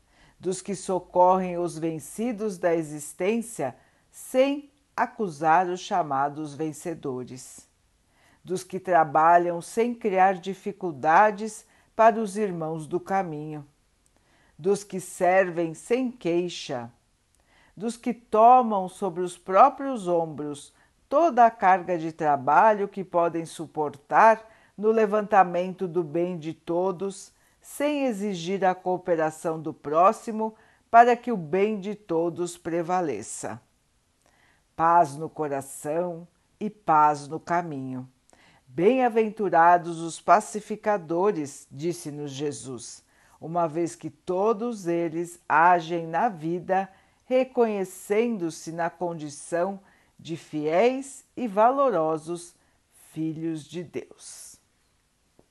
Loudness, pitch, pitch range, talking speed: -25 LUFS, 175 Hz, 160-210 Hz, 100 wpm